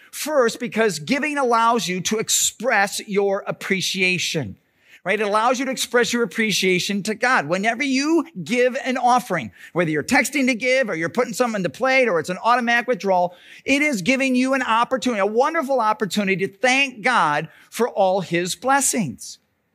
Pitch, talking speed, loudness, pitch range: 230 Hz, 175 wpm, -20 LUFS, 195-255 Hz